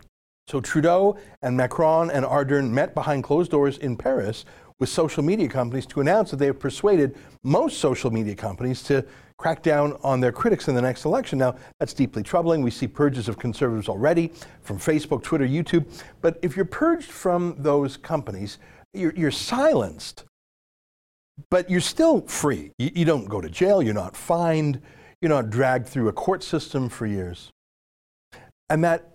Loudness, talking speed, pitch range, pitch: -23 LUFS, 175 wpm, 125-165 Hz, 145 Hz